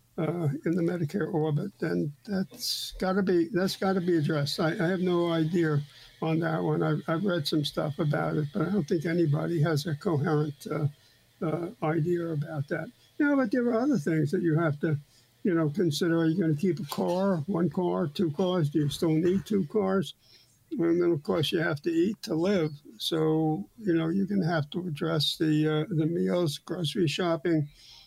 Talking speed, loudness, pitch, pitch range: 210 wpm, -28 LUFS, 165 Hz, 155-180 Hz